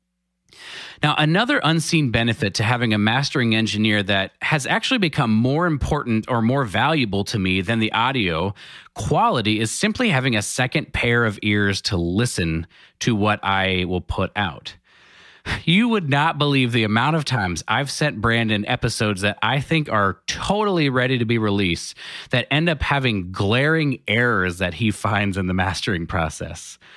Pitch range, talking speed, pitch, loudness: 100-140 Hz, 165 wpm, 110 Hz, -20 LUFS